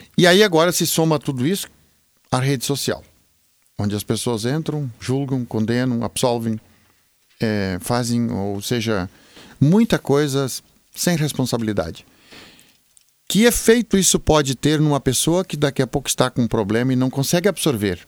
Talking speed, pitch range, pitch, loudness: 145 wpm, 115-155 Hz, 130 Hz, -19 LUFS